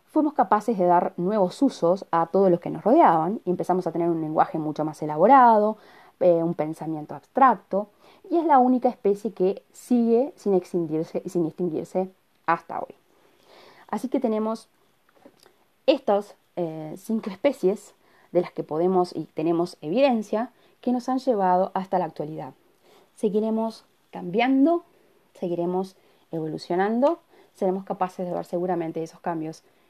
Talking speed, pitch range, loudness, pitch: 140 wpm, 175-230 Hz, -24 LUFS, 190 Hz